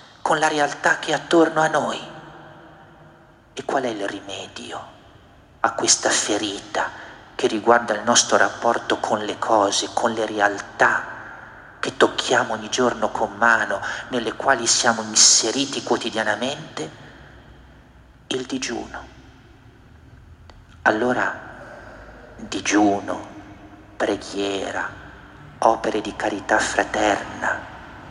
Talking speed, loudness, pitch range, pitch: 100 wpm, -20 LUFS, 110-155 Hz, 120 Hz